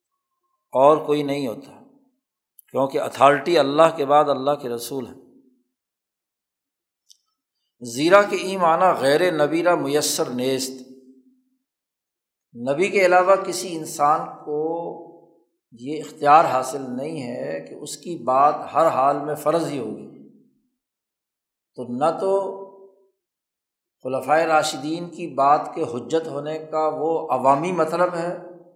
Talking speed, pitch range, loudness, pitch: 120 wpm, 145-195 Hz, -21 LUFS, 165 Hz